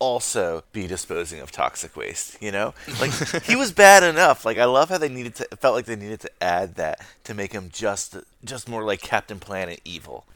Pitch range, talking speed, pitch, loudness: 95-135 Hz, 215 wpm, 110 Hz, -21 LUFS